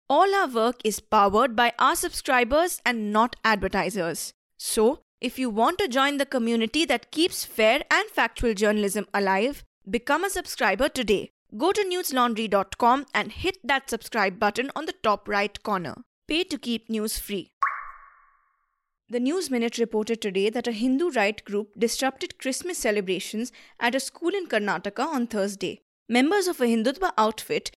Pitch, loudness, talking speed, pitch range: 245 Hz, -25 LUFS, 160 wpm, 215-315 Hz